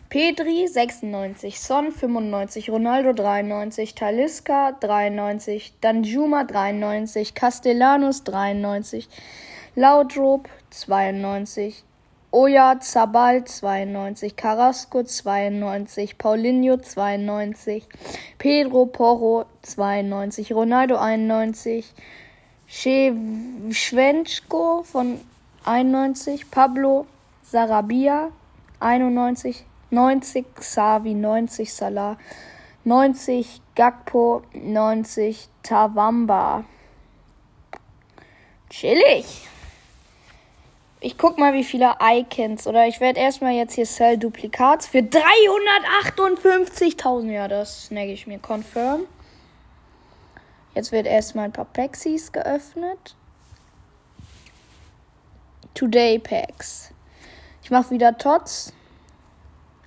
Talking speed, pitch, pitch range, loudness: 75 wpm, 235 Hz, 210-265 Hz, -20 LUFS